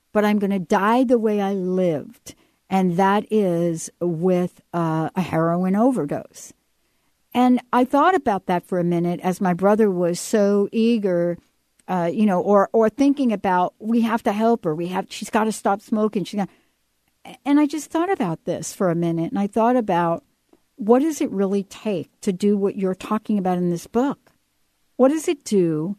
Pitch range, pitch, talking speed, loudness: 180-230 Hz, 200 Hz, 190 wpm, -21 LUFS